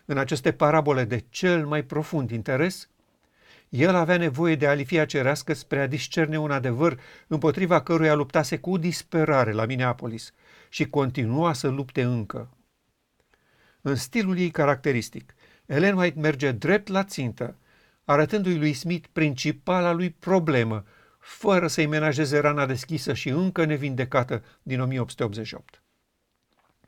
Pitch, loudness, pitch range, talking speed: 150 Hz, -24 LUFS, 130-165 Hz, 125 wpm